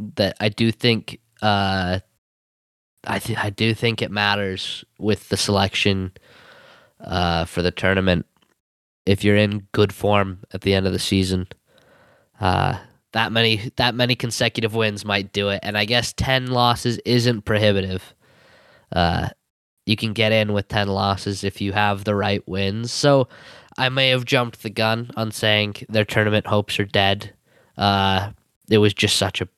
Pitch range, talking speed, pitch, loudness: 100-115 Hz, 165 wpm, 105 Hz, -20 LUFS